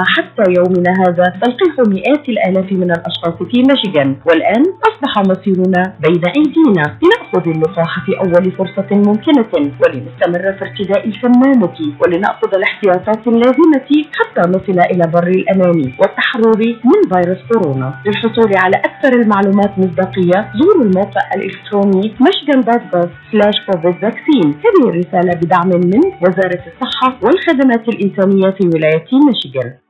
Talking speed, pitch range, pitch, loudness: 120 wpm, 180-250 Hz, 195 Hz, -12 LUFS